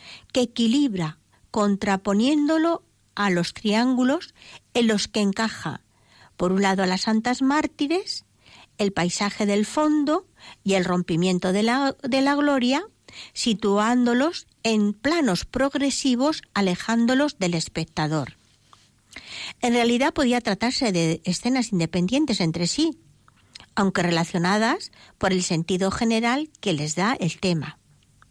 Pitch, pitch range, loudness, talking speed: 215 Hz, 180-265 Hz, -23 LUFS, 120 wpm